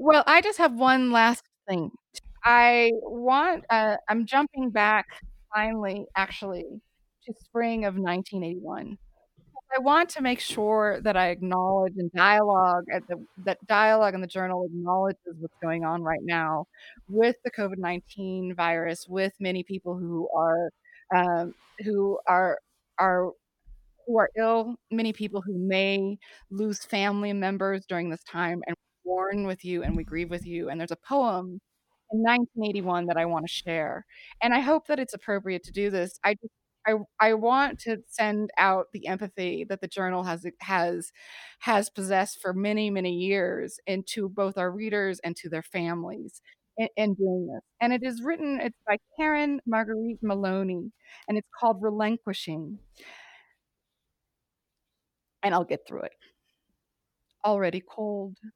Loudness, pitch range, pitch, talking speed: -26 LUFS, 180-225 Hz, 200 Hz, 155 wpm